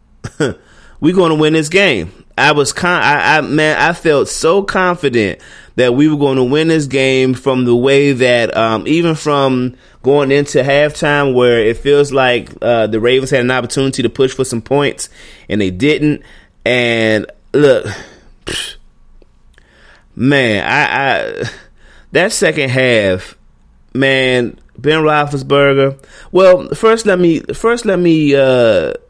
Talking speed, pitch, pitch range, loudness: 145 wpm, 140 Hz, 125-155 Hz, -12 LUFS